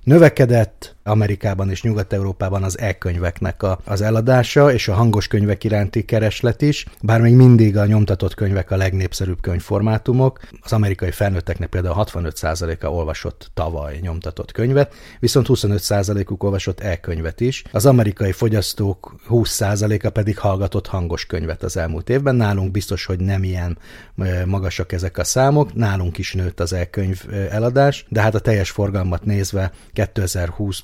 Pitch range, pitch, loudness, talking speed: 95-110 Hz, 100 Hz, -18 LUFS, 140 wpm